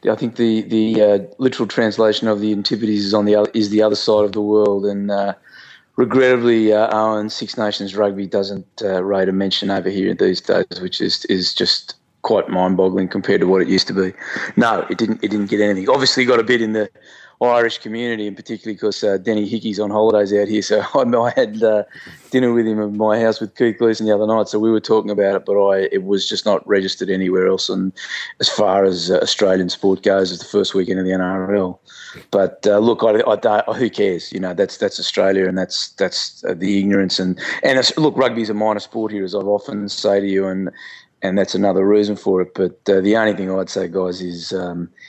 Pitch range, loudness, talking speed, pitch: 95-110 Hz, -17 LUFS, 235 wpm, 105 Hz